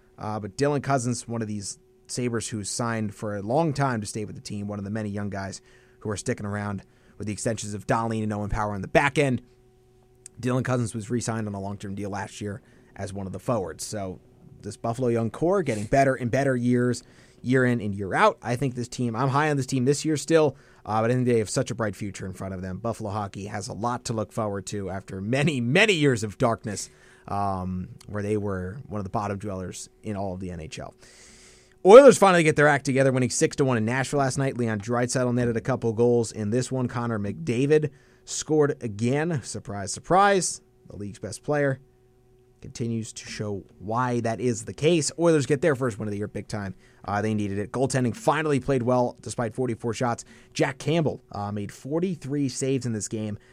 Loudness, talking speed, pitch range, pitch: -25 LUFS, 220 wpm, 105-130 Hz, 120 Hz